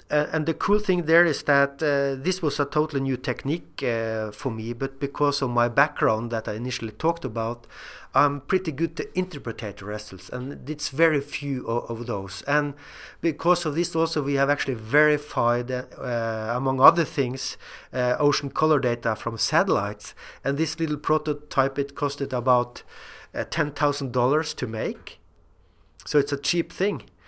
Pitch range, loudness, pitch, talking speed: 120-150 Hz, -25 LUFS, 140 Hz, 170 wpm